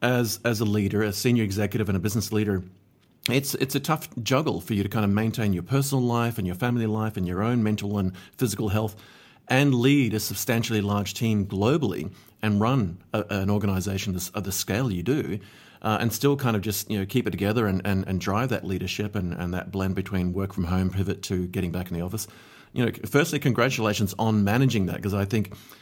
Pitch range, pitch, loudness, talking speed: 95-120 Hz, 105 Hz, -26 LUFS, 225 wpm